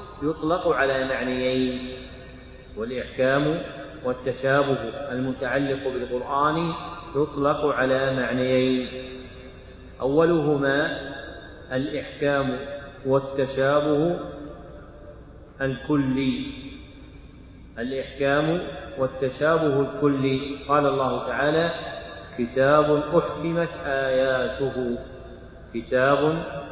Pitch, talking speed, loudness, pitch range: 135 Hz, 55 wpm, -24 LUFS, 130-145 Hz